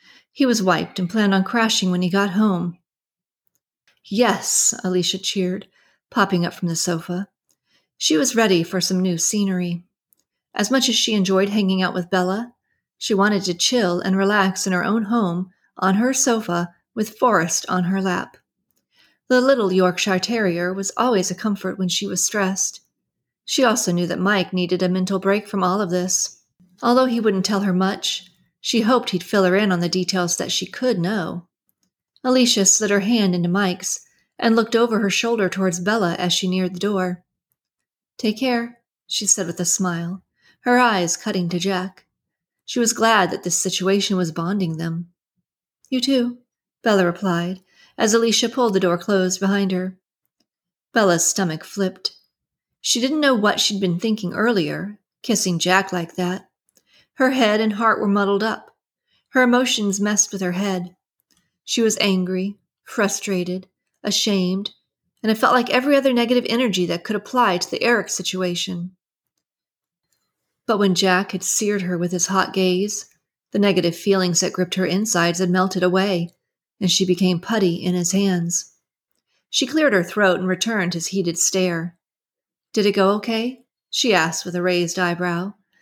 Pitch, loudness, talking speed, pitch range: 190 Hz, -20 LUFS, 170 wpm, 180-215 Hz